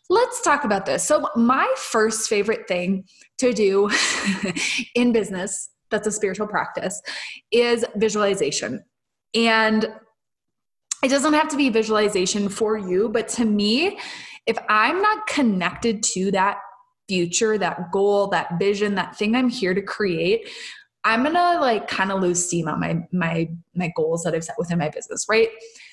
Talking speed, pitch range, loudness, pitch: 155 wpm, 190-245 Hz, -21 LUFS, 215 Hz